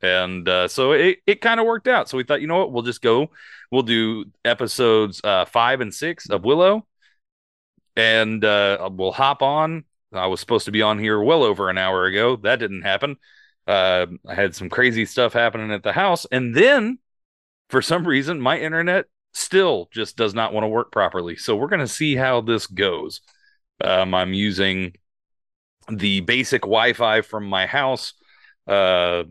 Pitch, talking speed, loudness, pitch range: 110 Hz, 185 wpm, -20 LUFS, 95-155 Hz